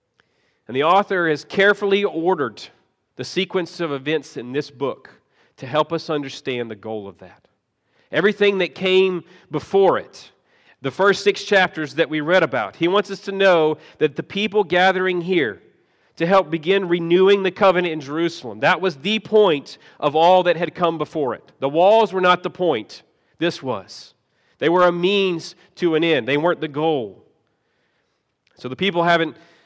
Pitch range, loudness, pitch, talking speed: 155-195 Hz, -19 LUFS, 175 Hz, 175 wpm